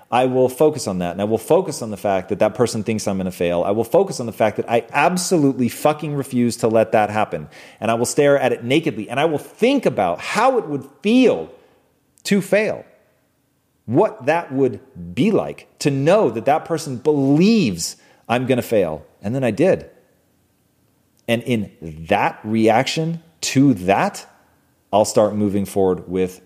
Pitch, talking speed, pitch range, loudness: 120 Hz, 190 wpm, 105-150 Hz, -19 LUFS